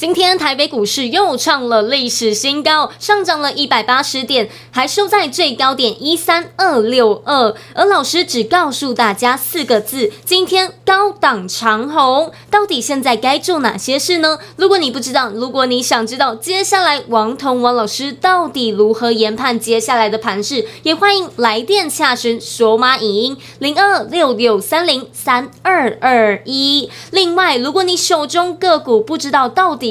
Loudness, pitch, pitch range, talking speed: -13 LUFS, 275 Hz, 235-345 Hz, 255 characters per minute